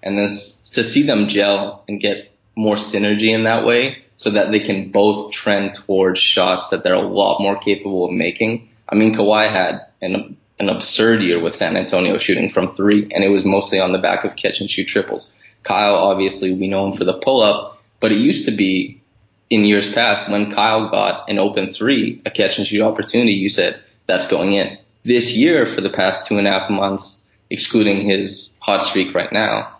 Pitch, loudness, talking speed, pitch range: 100 Hz, -17 LUFS, 210 wpm, 100-110 Hz